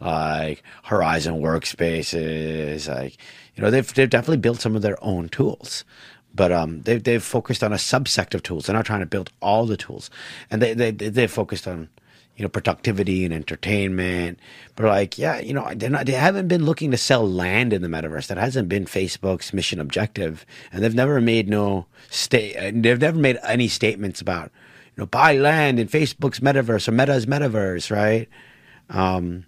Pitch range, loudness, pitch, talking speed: 90-120 Hz, -21 LUFS, 105 Hz, 185 wpm